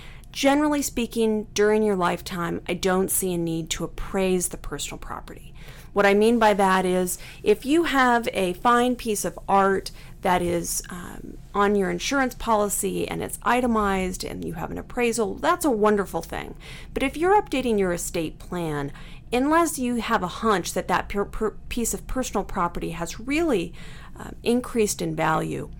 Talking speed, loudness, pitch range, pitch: 170 wpm, -24 LUFS, 175-235 Hz, 200 Hz